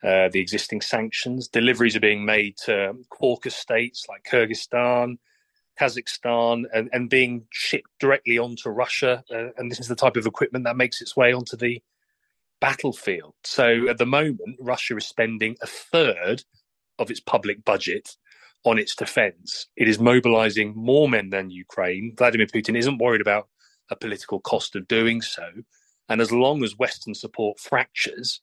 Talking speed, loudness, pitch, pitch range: 165 wpm, -22 LUFS, 120 Hz, 110-125 Hz